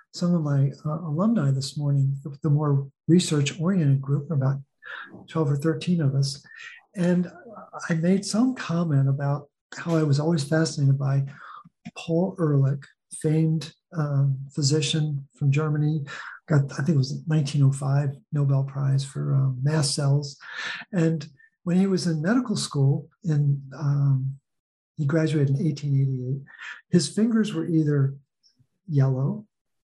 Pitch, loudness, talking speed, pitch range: 150 Hz, -24 LUFS, 135 wpm, 140-165 Hz